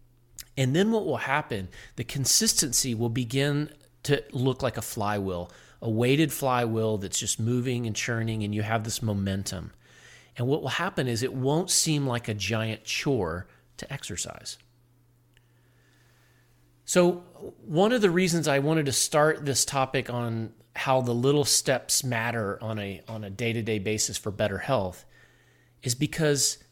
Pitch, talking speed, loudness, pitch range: 120 Hz, 160 wpm, -26 LUFS, 110-140 Hz